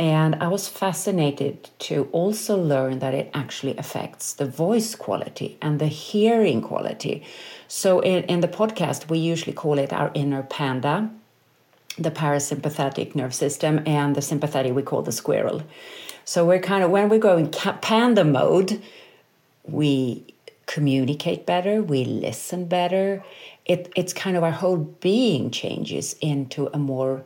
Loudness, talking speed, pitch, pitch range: -23 LUFS, 150 wpm, 165 Hz, 145-190 Hz